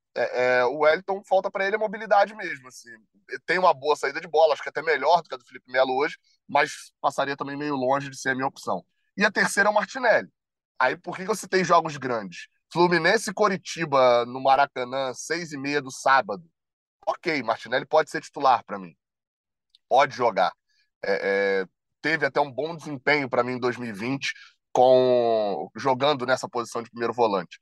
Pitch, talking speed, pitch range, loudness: 140 Hz, 195 wpm, 125-175 Hz, -24 LUFS